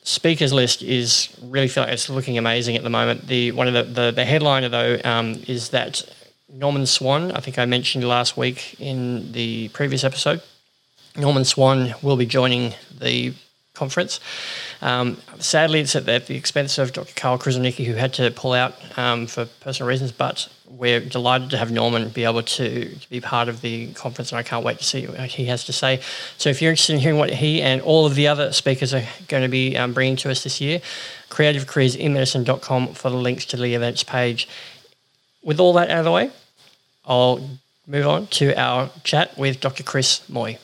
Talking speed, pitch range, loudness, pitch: 200 wpm, 120-140 Hz, -20 LUFS, 130 Hz